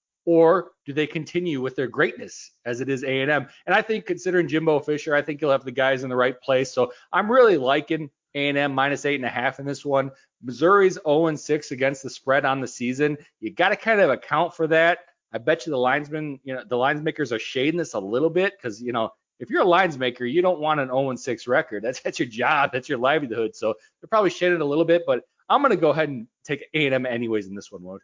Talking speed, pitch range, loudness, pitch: 240 wpm, 130-165 Hz, -23 LUFS, 145 Hz